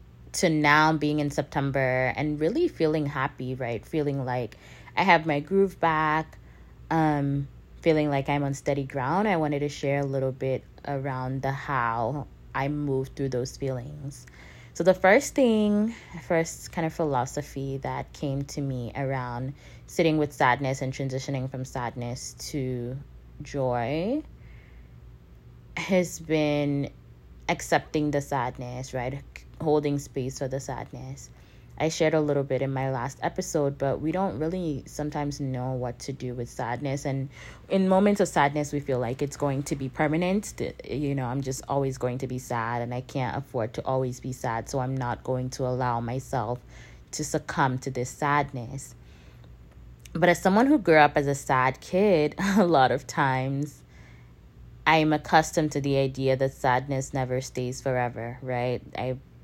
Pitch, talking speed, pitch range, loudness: 135 Hz, 165 wpm, 125-150 Hz, -27 LUFS